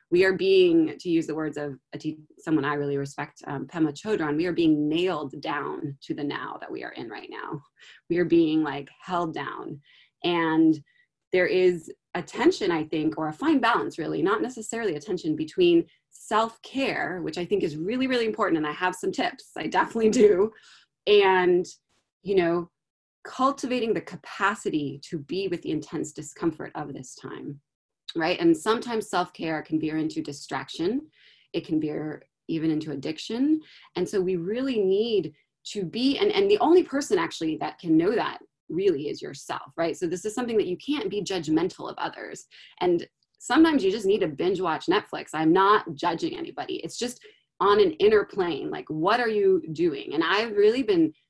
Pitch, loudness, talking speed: 210 Hz, -25 LUFS, 185 wpm